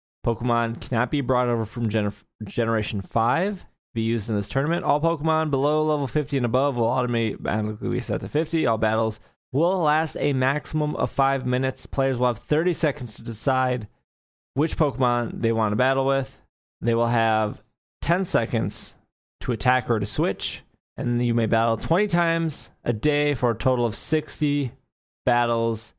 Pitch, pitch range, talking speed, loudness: 120 Hz, 115-145 Hz, 175 wpm, -24 LUFS